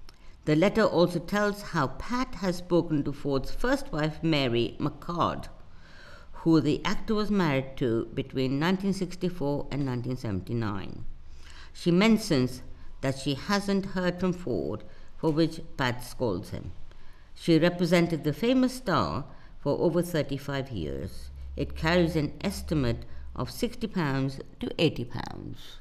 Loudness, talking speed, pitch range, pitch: -28 LUFS, 130 wpm, 120-175 Hz, 150 Hz